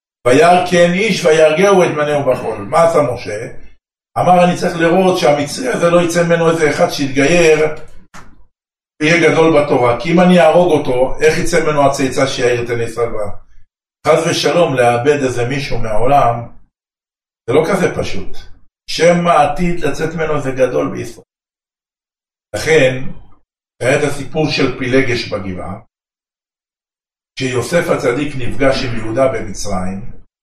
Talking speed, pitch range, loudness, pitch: 135 wpm, 120-170 Hz, -13 LUFS, 145 Hz